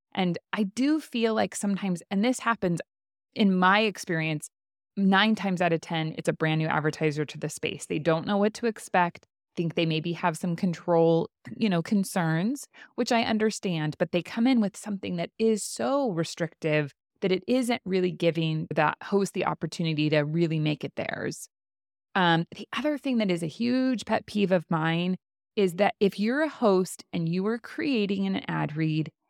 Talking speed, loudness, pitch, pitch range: 190 wpm, -27 LUFS, 185 Hz, 165-215 Hz